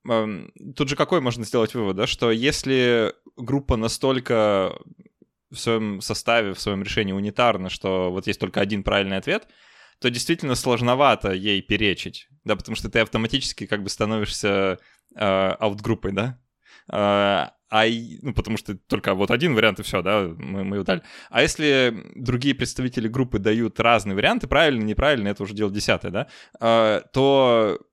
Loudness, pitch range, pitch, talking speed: -22 LUFS, 100-125 Hz, 110 Hz, 155 wpm